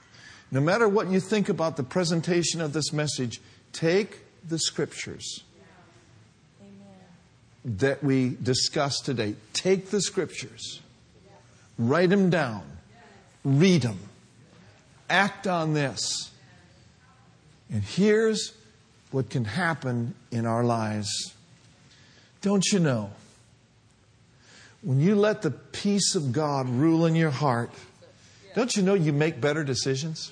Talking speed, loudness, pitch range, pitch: 115 wpm, -26 LUFS, 120-170 Hz, 135 Hz